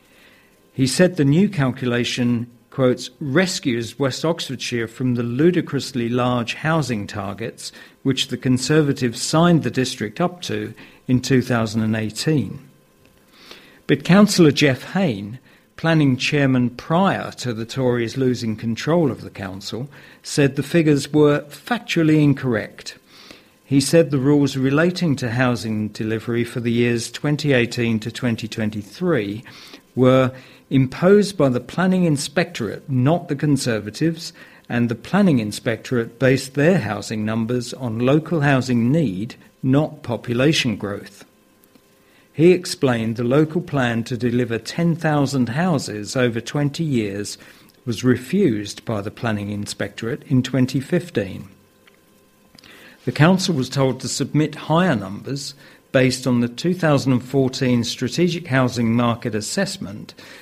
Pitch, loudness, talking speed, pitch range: 130 Hz, -20 LUFS, 120 wpm, 120-150 Hz